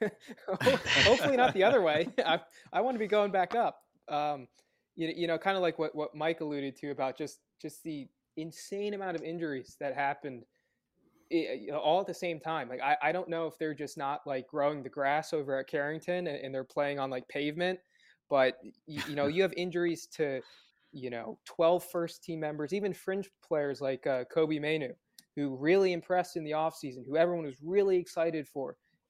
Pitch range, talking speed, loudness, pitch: 145-175 Hz, 200 wpm, -32 LUFS, 160 Hz